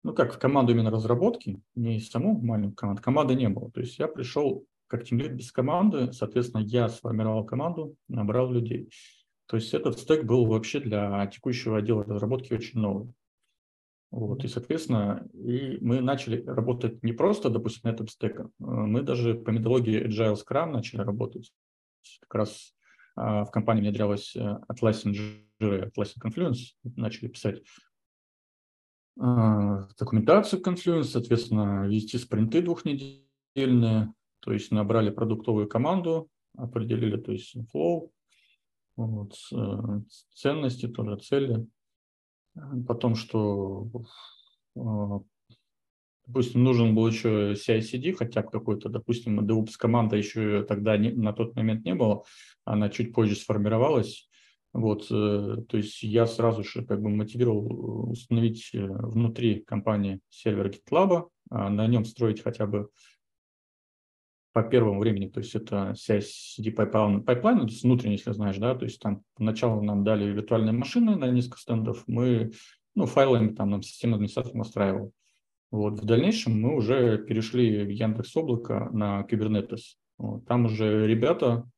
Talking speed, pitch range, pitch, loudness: 135 wpm, 105-120 Hz, 115 Hz, -27 LUFS